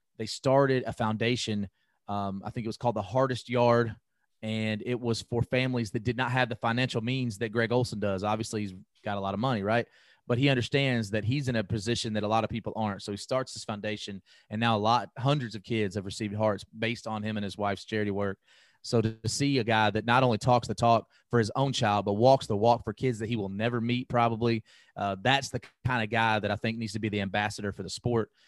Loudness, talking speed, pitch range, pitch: -29 LUFS, 250 wpm, 105-120 Hz, 115 Hz